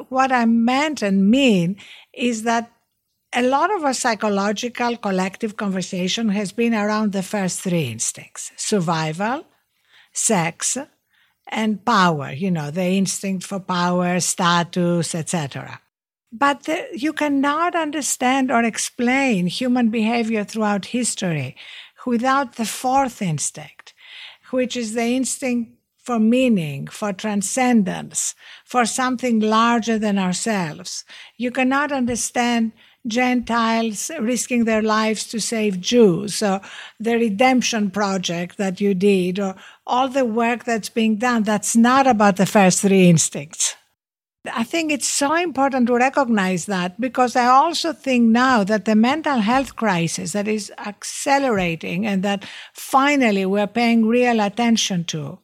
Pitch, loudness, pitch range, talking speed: 225 Hz, -19 LUFS, 195-250 Hz, 130 wpm